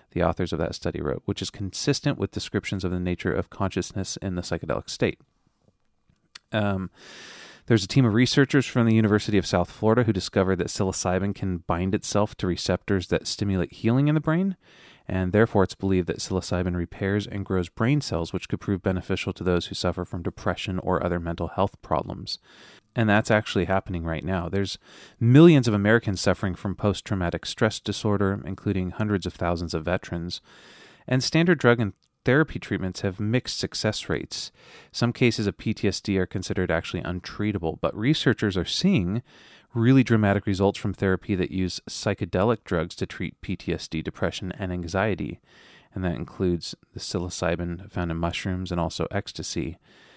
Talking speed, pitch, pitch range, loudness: 170 wpm, 95 Hz, 90-110 Hz, -25 LUFS